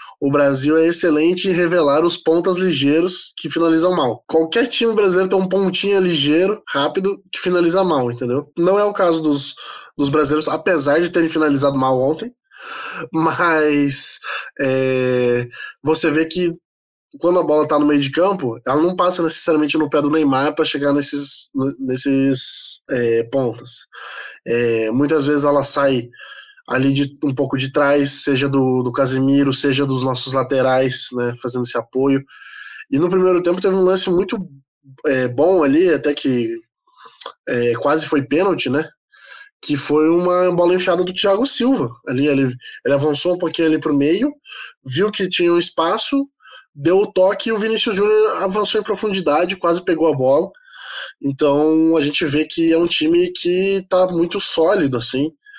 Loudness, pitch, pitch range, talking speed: -17 LUFS, 155 Hz, 140-185 Hz, 165 wpm